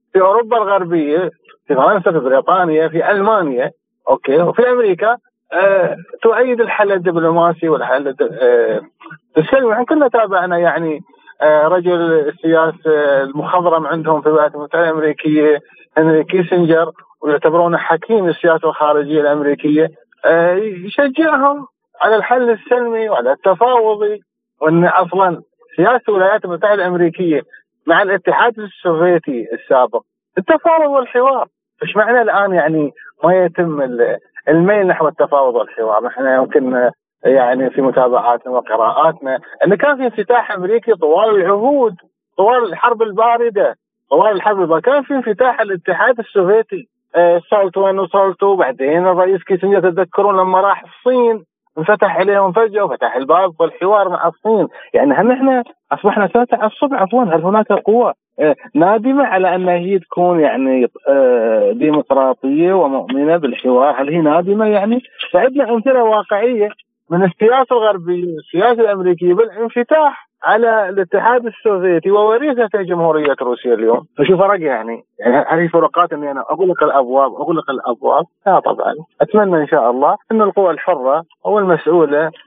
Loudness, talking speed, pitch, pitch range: -14 LUFS, 125 wpm, 190 Hz, 160-235 Hz